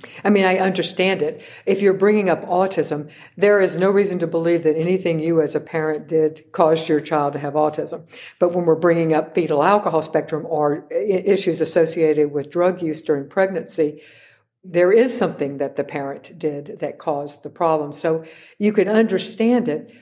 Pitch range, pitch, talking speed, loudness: 155-190 Hz, 165 Hz, 185 wpm, -19 LUFS